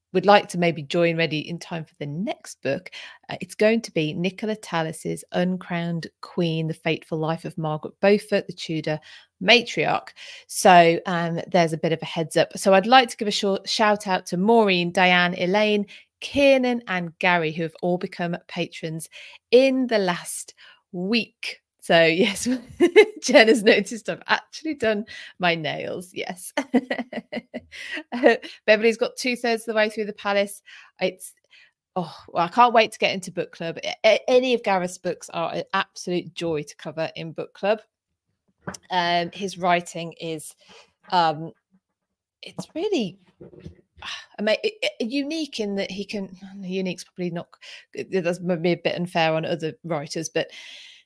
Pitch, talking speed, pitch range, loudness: 190 Hz, 160 wpm, 170-230 Hz, -22 LUFS